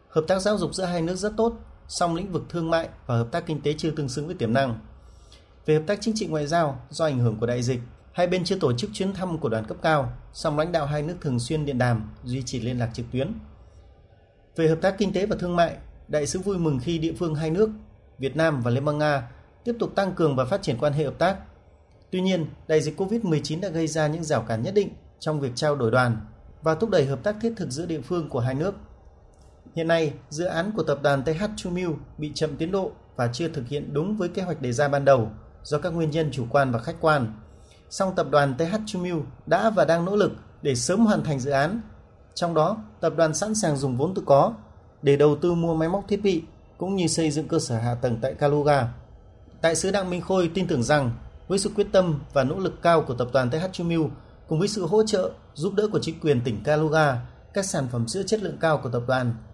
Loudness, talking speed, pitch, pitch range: -25 LUFS, 250 wpm, 155 Hz, 130-180 Hz